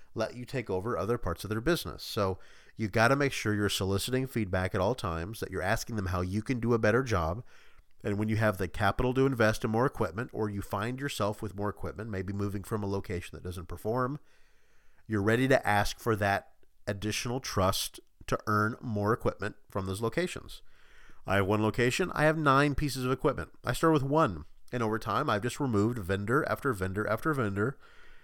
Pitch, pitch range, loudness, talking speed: 110 Hz, 100-130 Hz, -30 LUFS, 210 wpm